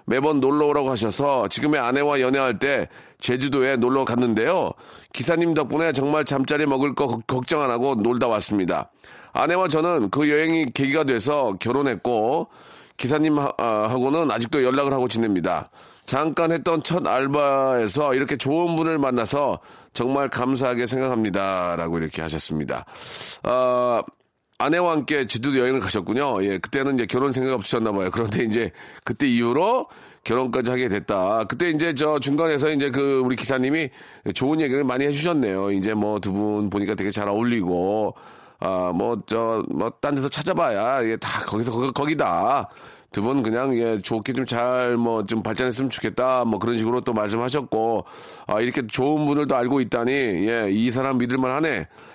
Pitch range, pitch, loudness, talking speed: 115-145 Hz, 130 Hz, -22 LUFS, 350 characters per minute